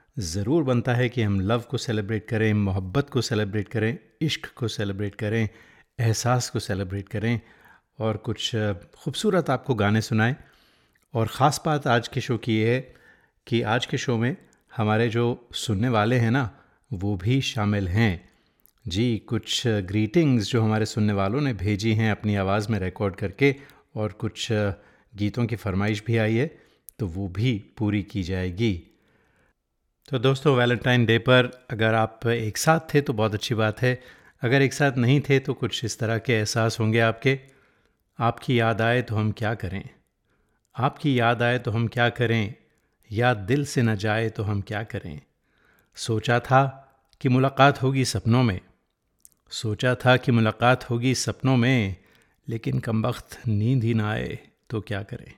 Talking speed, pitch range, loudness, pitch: 165 wpm, 105-125 Hz, -24 LUFS, 115 Hz